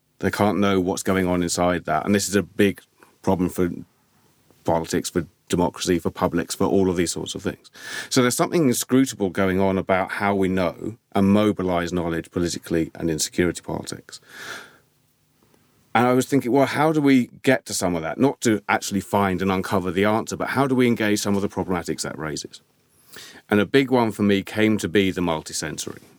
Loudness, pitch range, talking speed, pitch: -22 LUFS, 90-105 Hz, 200 wpm, 95 Hz